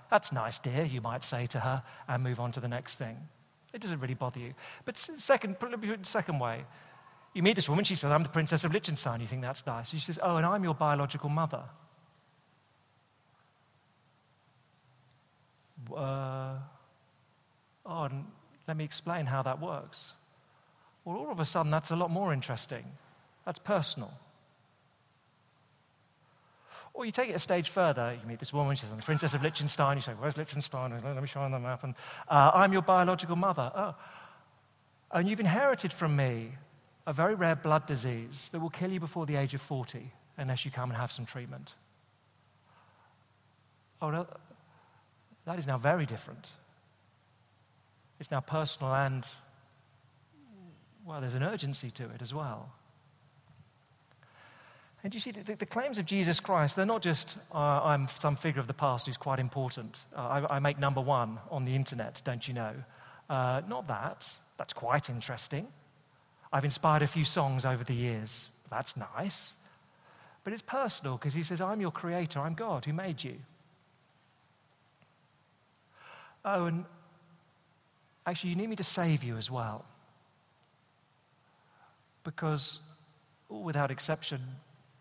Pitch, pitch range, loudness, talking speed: 145 Hz, 130-165 Hz, -33 LUFS, 155 wpm